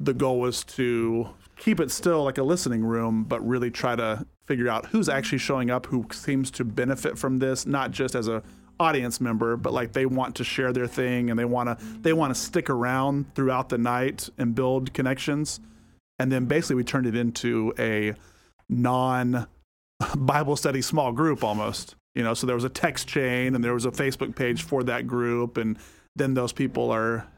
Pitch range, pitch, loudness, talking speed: 115-135 Hz, 125 Hz, -26 LUFS, 200 wpm